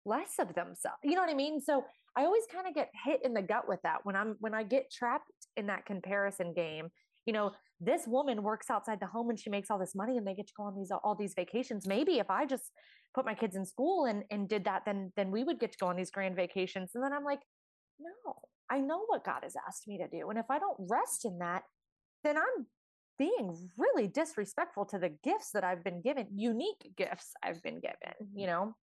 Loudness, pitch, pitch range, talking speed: -36 LUFS, 220 Hz, 195-275 Hz, 245 wpm